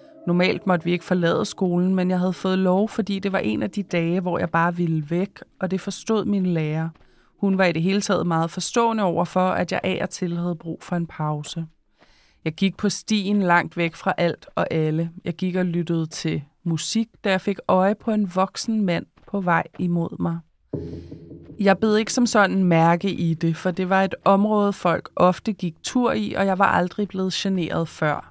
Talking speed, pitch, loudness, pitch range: 215 wpm, 185 Hz, -22 LUFS, 170-195 Hz